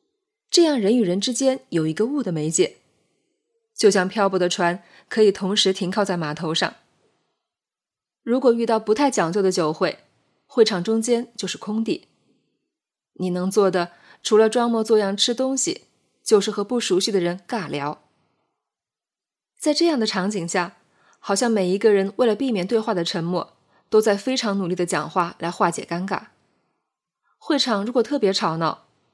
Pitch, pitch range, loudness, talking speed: 210 Hz, 185-240 Hz, -21 LUFS, 240 characters per minute